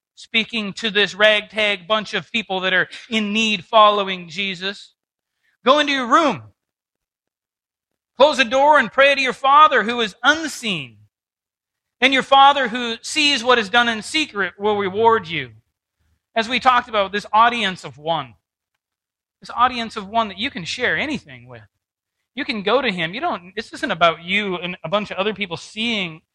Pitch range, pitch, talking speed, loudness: 180-245 Hz, 215 Hz, 175 wpm, -18 LUFS